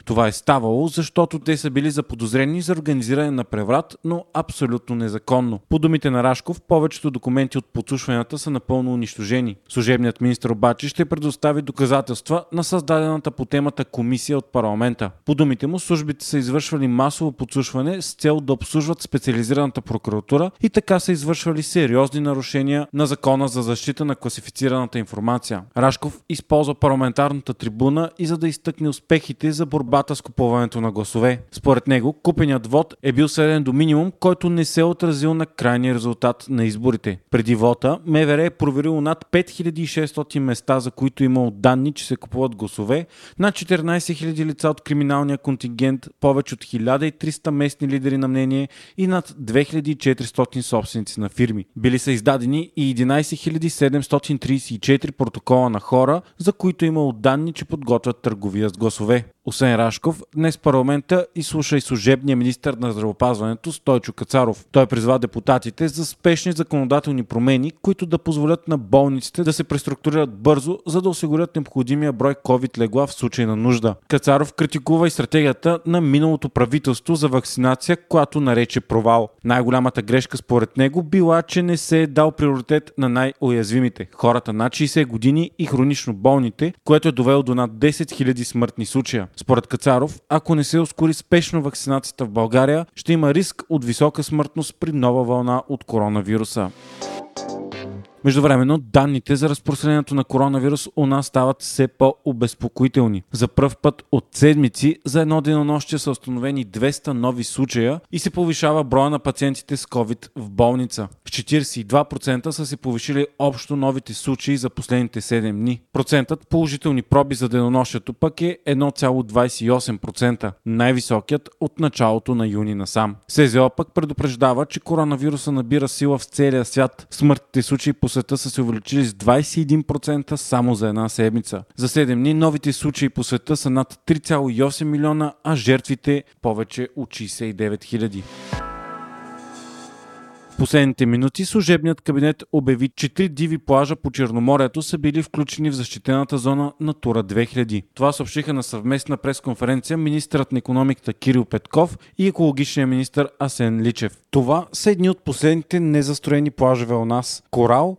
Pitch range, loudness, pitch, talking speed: 125-155 Hz, -20 LUFS, 135 Hz, 155 wpm